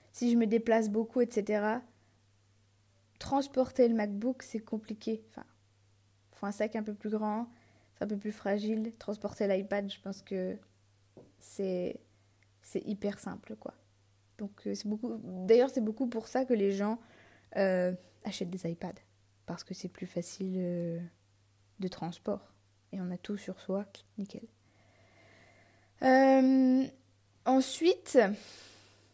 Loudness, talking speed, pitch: -32 LUFS, 140 wpm, 195 Hz